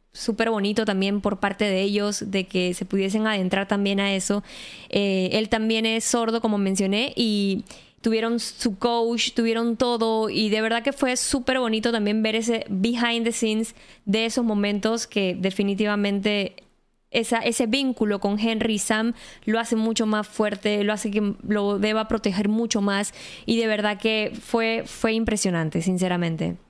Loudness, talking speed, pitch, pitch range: -23 LUFS, 165 wpm, 215 Hz, 205-230 Hz